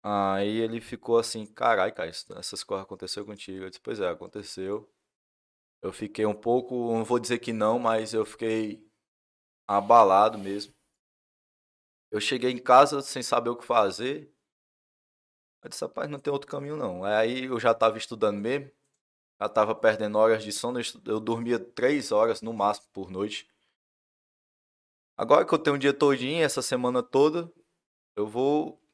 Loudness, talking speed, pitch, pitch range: -26 LUFS, 160 wpm, 115 Hz, 105-125 Hz